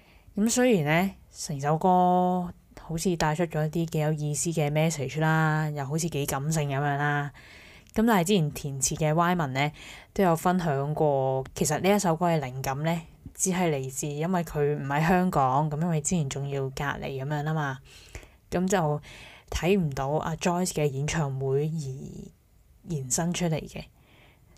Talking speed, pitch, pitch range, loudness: 265 characters per minute, 155 Hz, 140-175 Hz, -27 LUFS